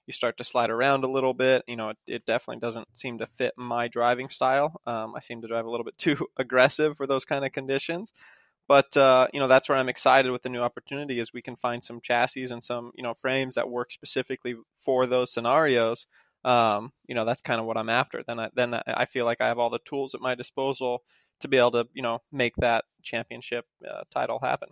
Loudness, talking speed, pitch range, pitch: -26 LUFS, 240 wpm, 120-135 Hz, 125 Hz